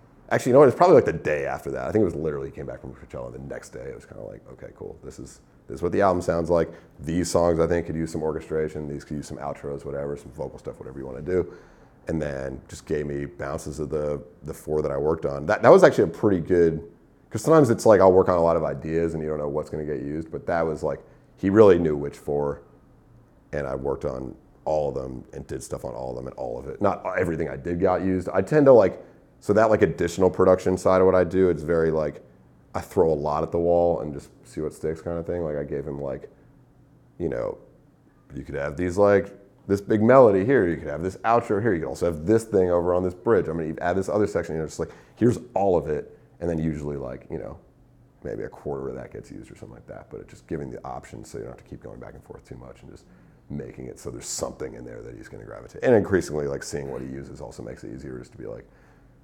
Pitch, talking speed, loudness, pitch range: 80 Hz, 285 wpm, -23 LUFS, 70-90 Hz